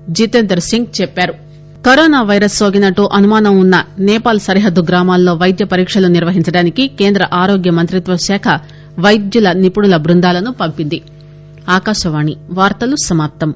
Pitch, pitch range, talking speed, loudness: 185 Hz, 170-205 Hz, 95 wpm, -11 LUFS